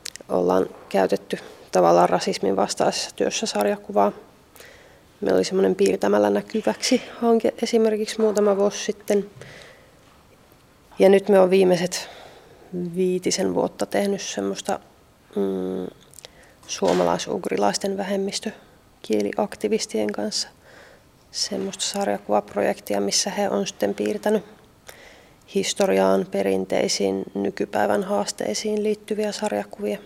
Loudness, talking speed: -22 LUFS, 85 wpm